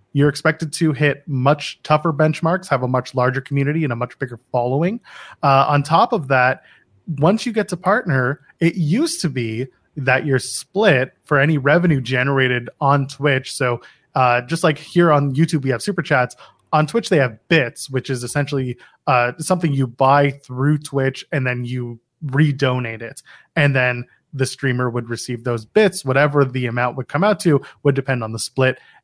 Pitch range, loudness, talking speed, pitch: 125-155 Hz, -18 LUFS, 185 wpm, 140 Hz